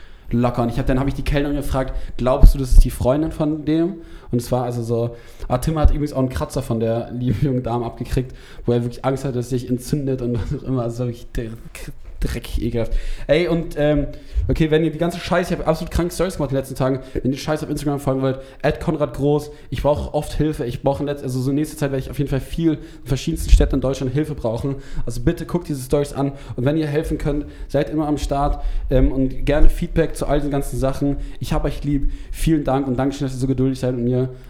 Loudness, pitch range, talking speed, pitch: -22 LUFS, 125-150 Hz, 255 wpm, 140 Hz